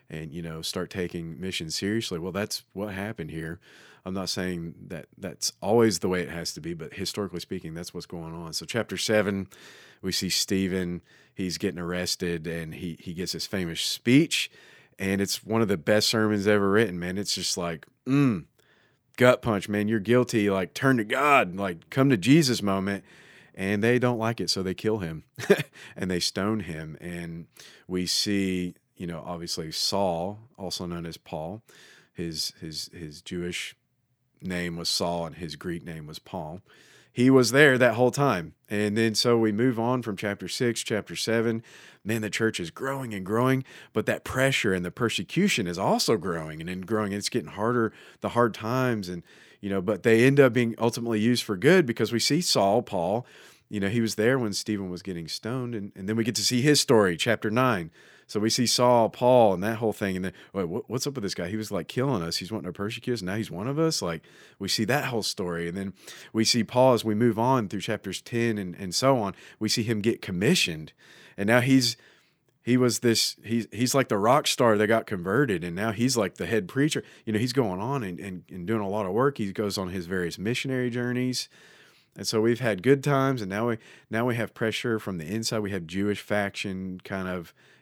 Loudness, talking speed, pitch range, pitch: -26 LUFS, 215 wpm, 90-120 Hz, 105 Hz